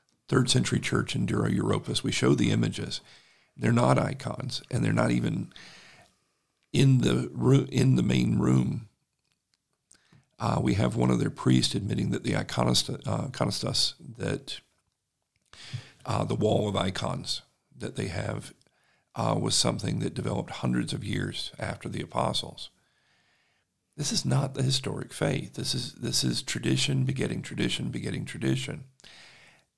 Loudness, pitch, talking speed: -28 LUFS, 95 Hz, 145 wpm